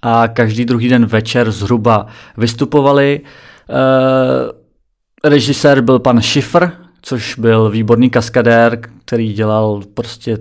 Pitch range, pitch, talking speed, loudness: 115-130 Hz, 120 Hz, 110 wpm, -12 LUFS